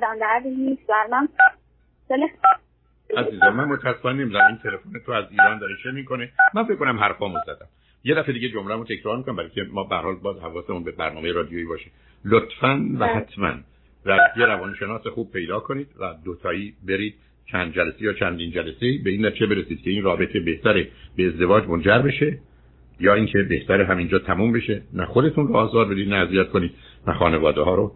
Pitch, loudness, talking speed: 110 Hz, -21 LUFS, 170 wpm